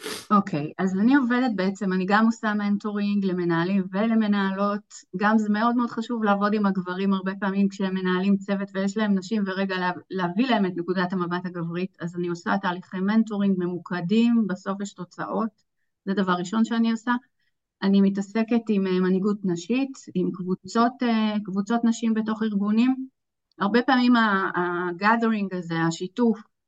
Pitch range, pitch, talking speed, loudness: 185-225 Hz, 200 Hz, 150 wpm, -24 LUFS